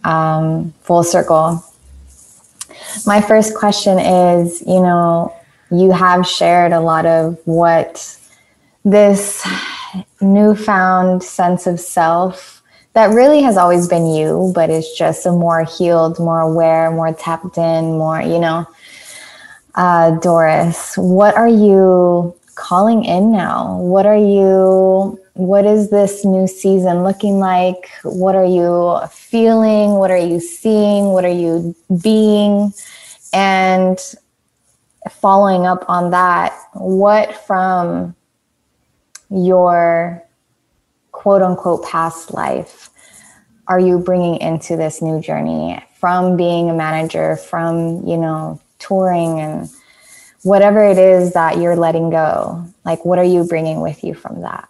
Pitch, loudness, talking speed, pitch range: 180 Hz, -13 LUFS, 125 wpm, 165-195 Hz